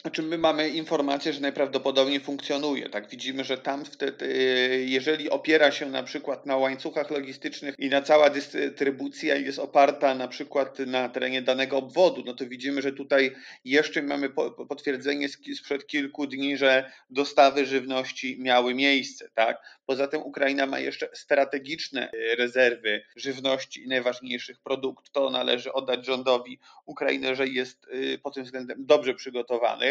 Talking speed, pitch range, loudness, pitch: 140 wpm, 130-140 Hz, -26 LUFS, 135 Hz